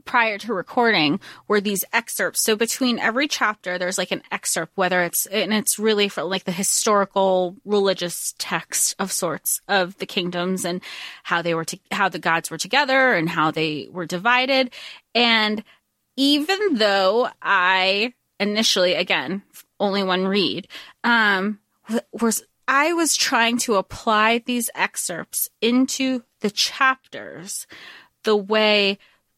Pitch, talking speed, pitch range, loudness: 210 Hz, 140 wpm, 185-240 Hz, -20 LUFS